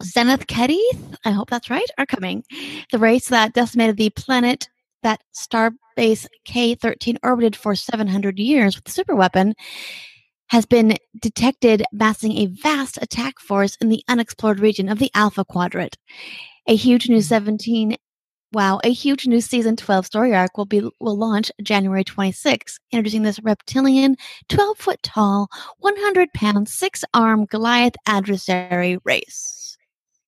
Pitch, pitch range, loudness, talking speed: 225 Hz, 210-245 Hz, -19 LUFS, 150 wpm